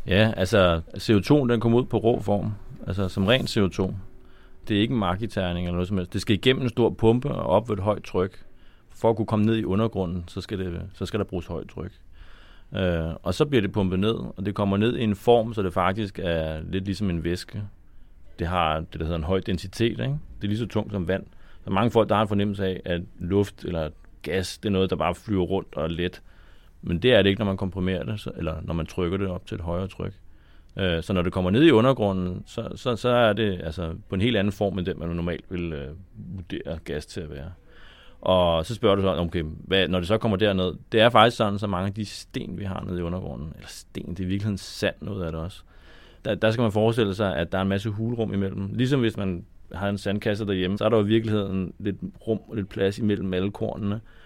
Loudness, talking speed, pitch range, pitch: -25 LUFS, 250 wpm, 90-110 Hz, 95 Hz